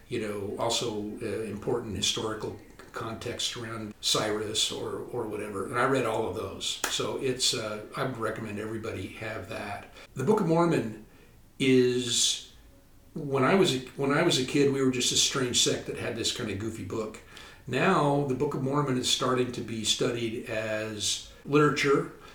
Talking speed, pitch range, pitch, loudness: 175 wpm, 110-135 Hz, 120 Hz, -28 LUFS